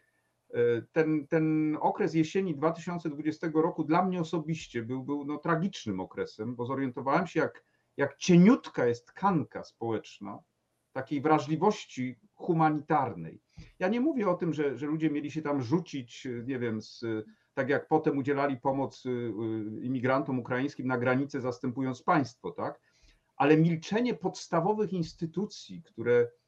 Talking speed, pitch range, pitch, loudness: 130 wpm, 125-165 Hz, 150 Hz, -30 LUFS